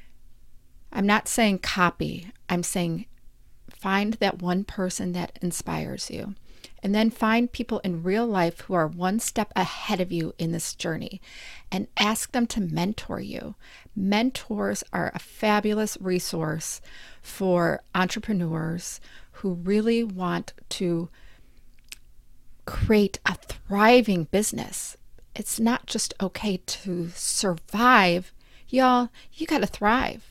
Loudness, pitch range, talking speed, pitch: -25 LUFS, 175-220 Hz, 125 wpm, 195 Hz